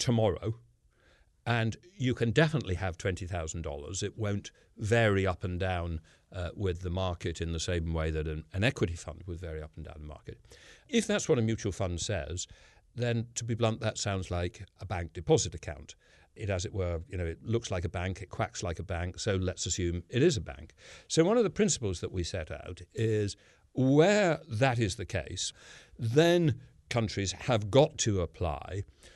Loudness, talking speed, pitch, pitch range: -31 LUFS, 195 wpm, 95 Hz, 85-115 Hz